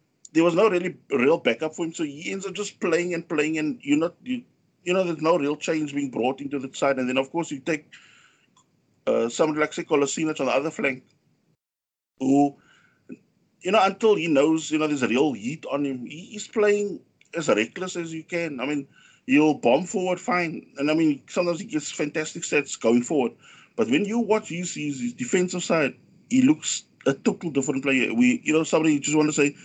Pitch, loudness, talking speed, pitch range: 160 Hz, -24 LUFS, 215 wpm, 145-185 Hz